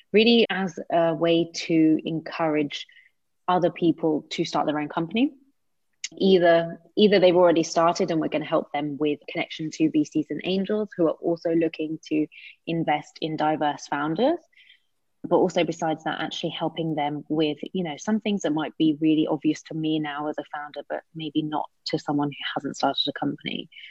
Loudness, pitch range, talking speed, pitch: -24 LUFS, 155-175 Hz, 180 wpm, 160 Hz